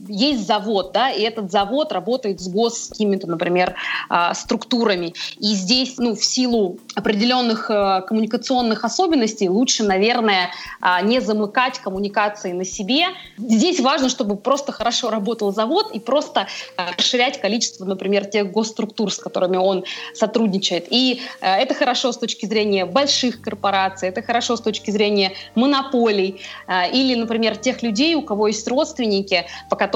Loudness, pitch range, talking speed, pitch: -19 LUFS, 195-245 Hz, 140 wpm, 220 Hz